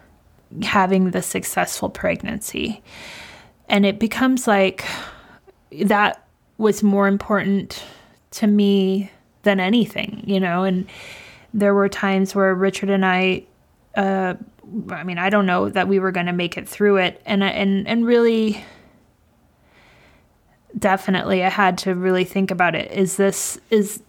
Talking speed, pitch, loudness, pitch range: 140 wpm, 195 Hz, -19 LUFS, 185-205 Hz